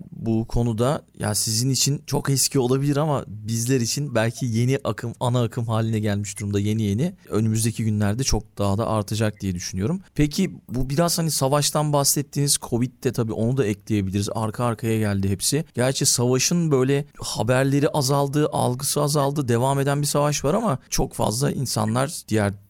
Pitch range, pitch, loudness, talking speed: 110-145 Hz, 125 Hz, -22 LUFS, 165 wpm